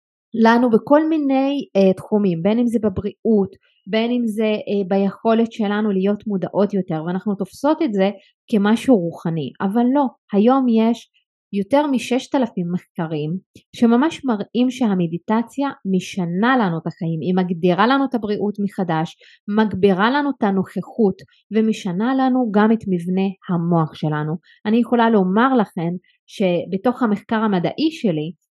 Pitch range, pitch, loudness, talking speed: 185-235 Hz, 210 Hz, -19 LUFS, 130 wpm